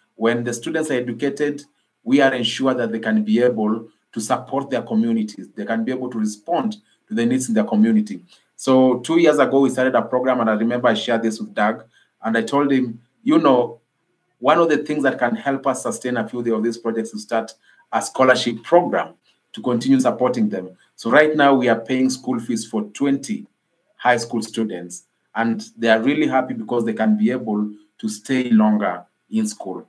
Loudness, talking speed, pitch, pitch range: -20 LUFS, 205 wpm, 125 Hz, 115-145 Hz